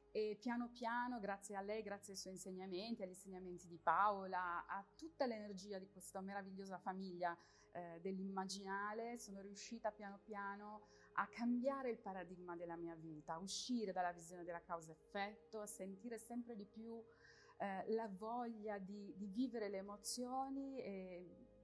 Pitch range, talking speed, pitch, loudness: 185-225 Hz, 150 wpm, 200 Hz, -48 LUFS